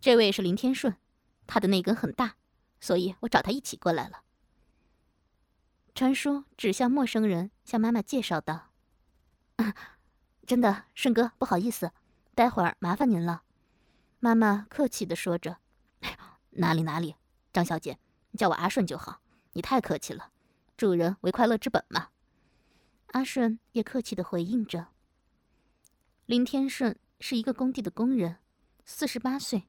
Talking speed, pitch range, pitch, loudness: 220 characters per minute, 180-255 Hz, 230 Hz, -29 LUFS